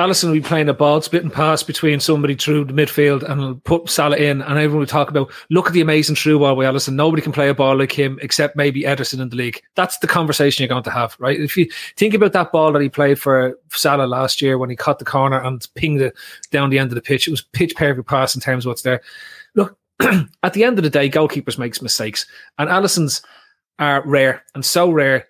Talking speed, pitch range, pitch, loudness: 250 wpm, 135-155 Hz, 145 Hz, -17 LUFS